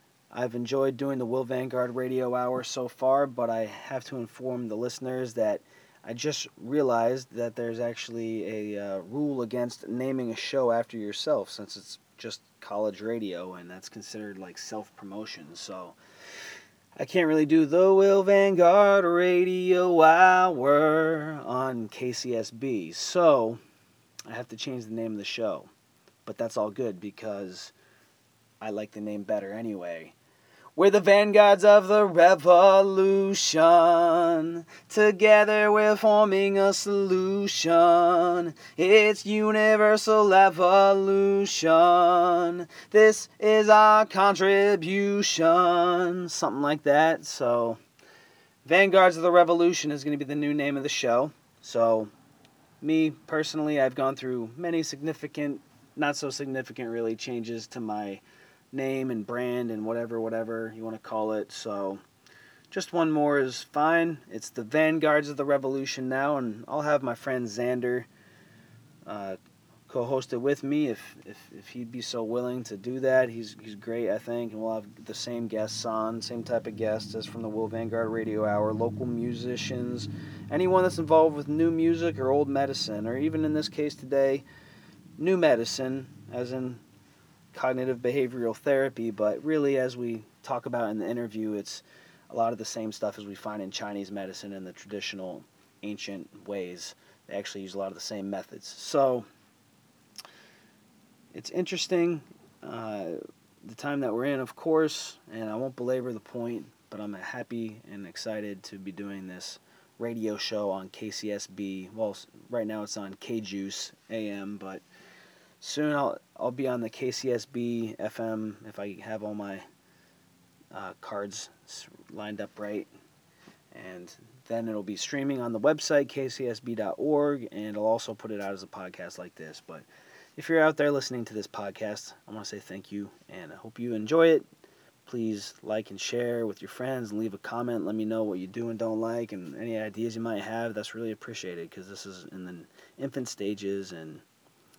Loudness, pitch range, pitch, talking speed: -26 LUFS, 110-155 Hz, 125 Hz, 160 wpm